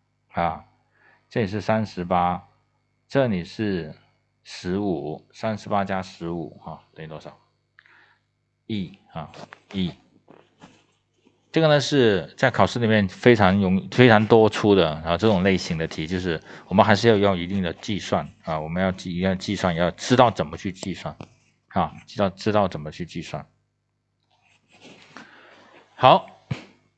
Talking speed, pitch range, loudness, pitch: 210 characters per minute, 90-110 Hz, -22 LUFS, 100 Hz